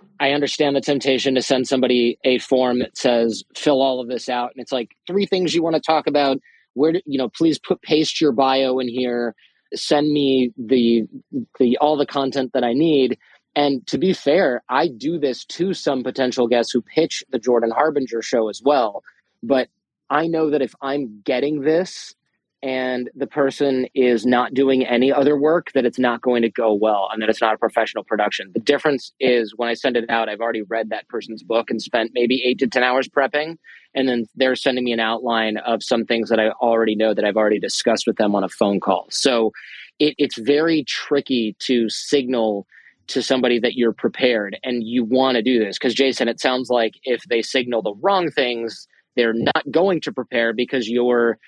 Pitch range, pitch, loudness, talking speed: 115-140 Hz, 125 Hz, -20 LUFS, 210 wpm